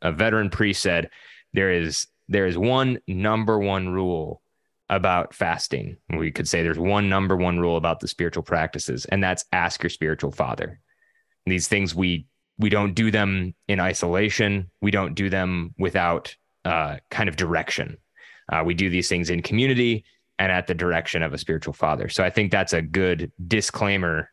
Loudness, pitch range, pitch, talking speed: -23 LUFS, 85-105 Hz, 95 Hz, 180 wpm